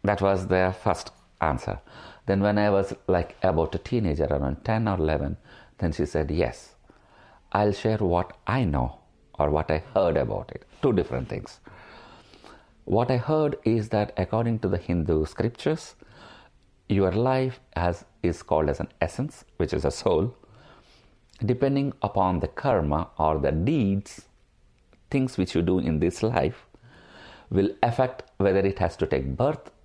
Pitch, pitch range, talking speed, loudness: 95 Hz, 85-110 Hz, 160 wpm, -26 LUFS